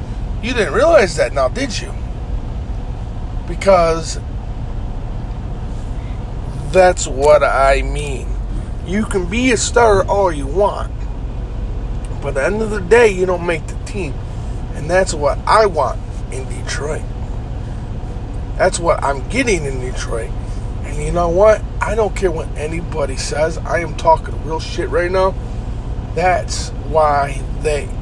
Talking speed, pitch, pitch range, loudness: 140 wpm, 120 Hz, 110-160 Hz, -18 LUFS